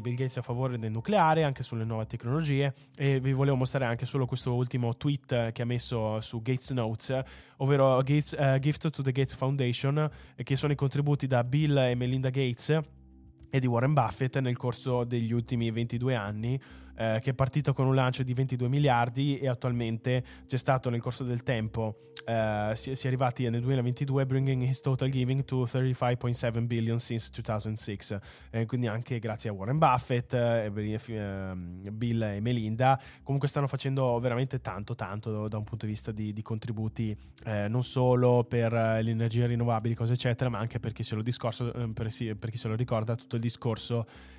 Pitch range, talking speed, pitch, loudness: 115-130 Hz, 185 wpm, 125 Hz, -30 LUFS